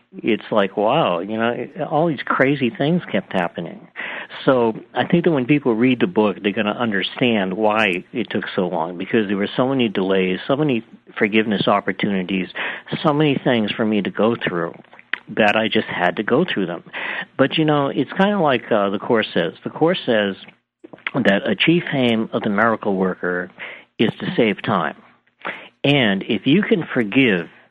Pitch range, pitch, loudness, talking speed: 105-140 Hz, 115 Hz, -19 LUFS, 185 wpm